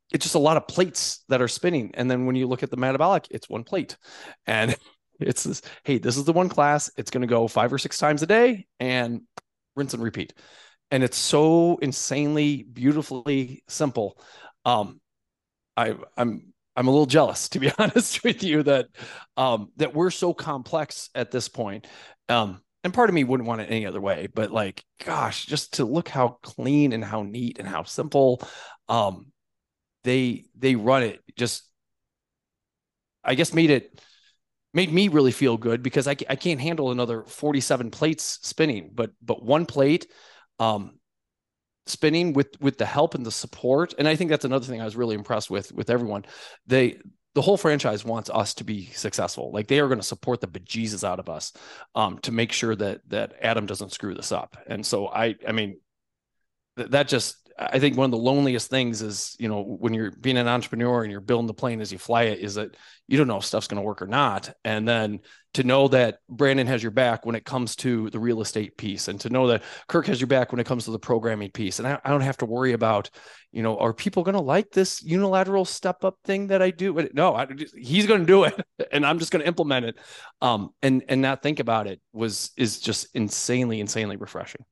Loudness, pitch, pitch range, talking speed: -24 LUFS, 130 Hz, 115-150 Hz, 215 wpm